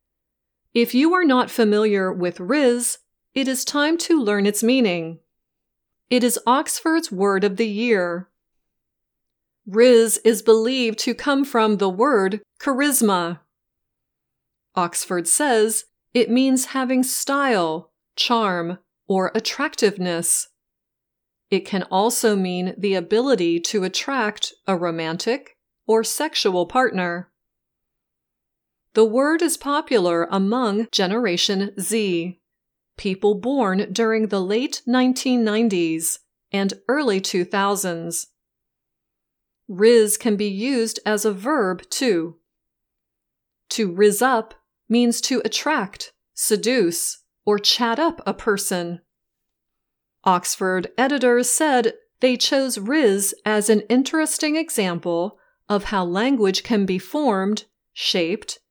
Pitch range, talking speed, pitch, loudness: 190-250 Hz, 105 wpm, 220 Hz, -20 LUFS